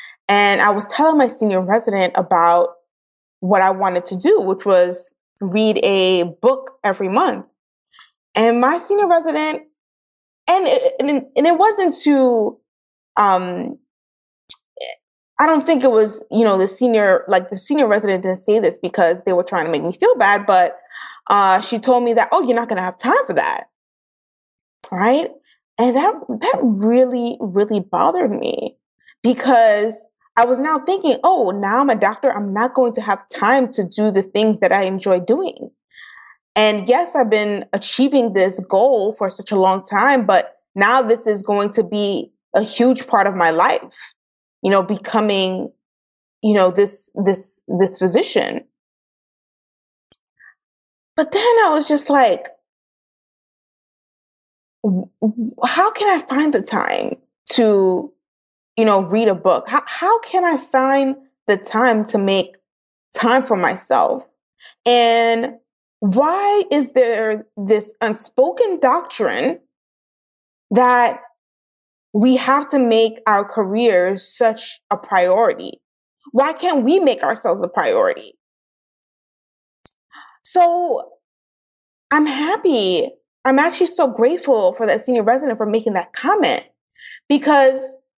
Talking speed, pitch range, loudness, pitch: 140 wpm, 200-275 Hz, -16 LUFS, 230 Hz